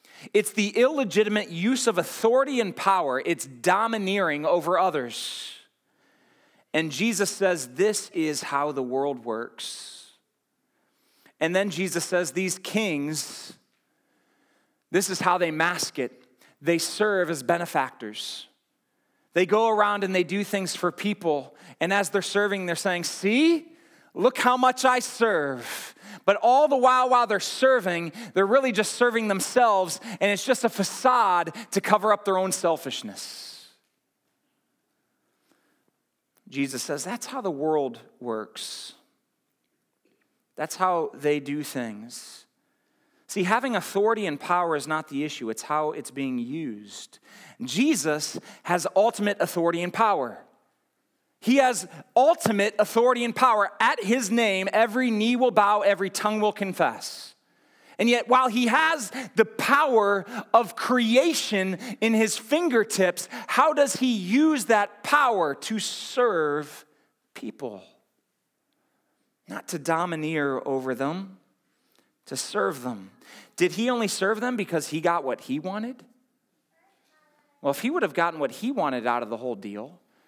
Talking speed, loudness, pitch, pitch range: 140 wpm, -24 LUFS, 205 Hz, 170-245 Hz